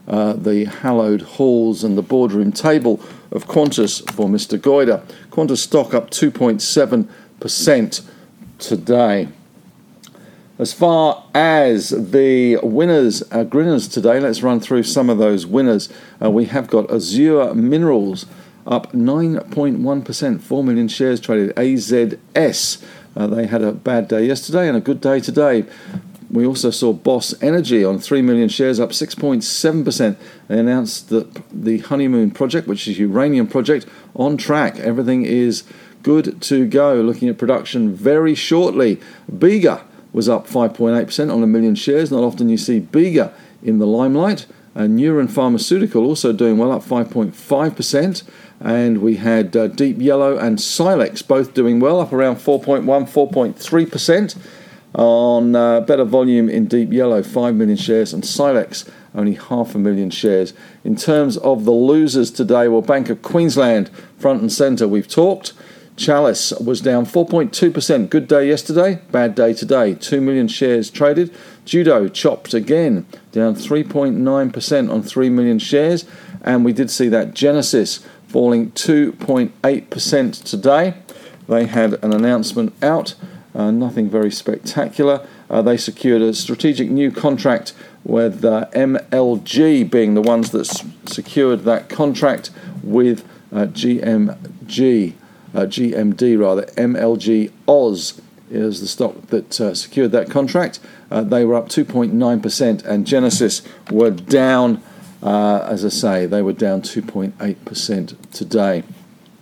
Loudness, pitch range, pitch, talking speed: -16 LUFS, 115-160 Hz, 130 Hz, 140 wpm